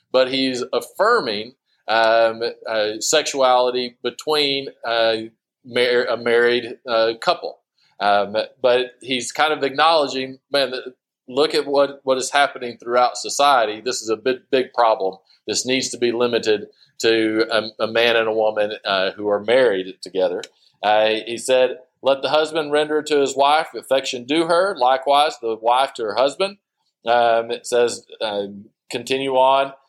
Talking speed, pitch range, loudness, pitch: 155 wpm, 115-140 Hz, -19 LUFS, 125 Hz